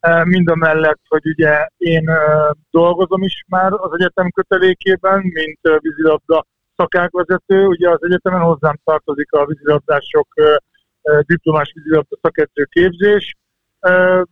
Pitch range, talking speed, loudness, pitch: 155-185 Hz, 110 wpm, -14 LUFS, 165 Hz